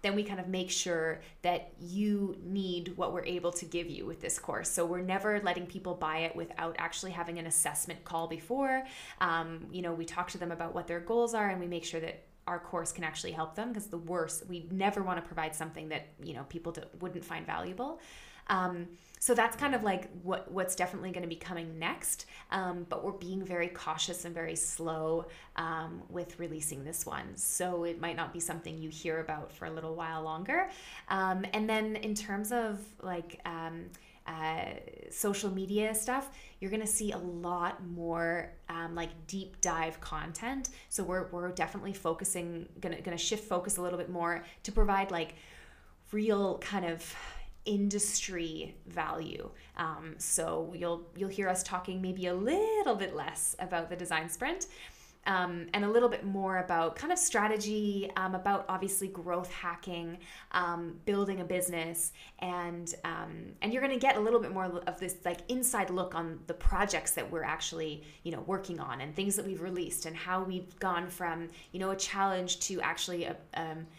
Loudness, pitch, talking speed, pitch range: -35 LUFS, 180 Hz, 190 wpm, 170-195 Hz